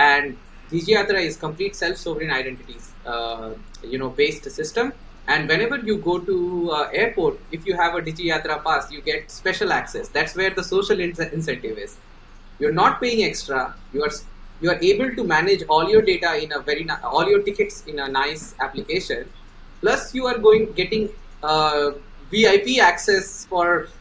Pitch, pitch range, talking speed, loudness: 185 Hz, 155-255 Hz, 175 wpm, -21 LUFS